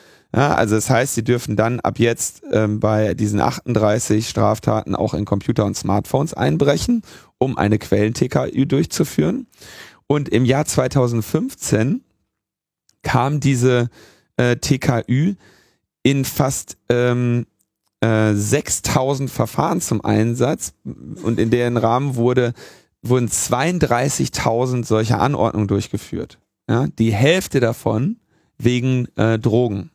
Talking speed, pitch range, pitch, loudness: 115 wpm, 110-135 Hz, 120 Hz, -19 LUFS